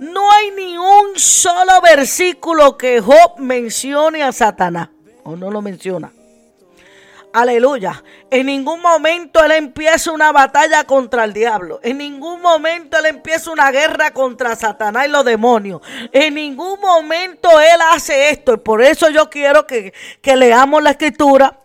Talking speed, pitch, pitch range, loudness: 150 wpm, 290 Hz, 245-325 Hz, -12 LUFS